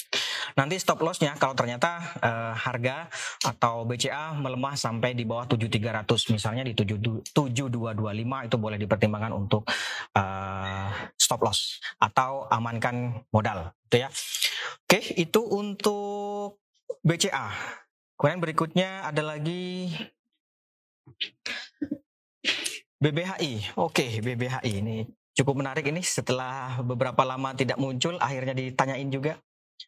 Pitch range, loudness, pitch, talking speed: 115-165 Hz, -28 LUFS, 130 Hz, 105 wpm